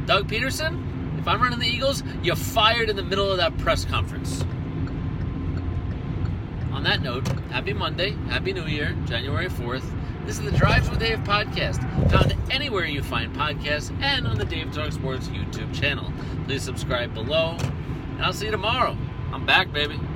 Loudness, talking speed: -24 LUFS, 170 wpm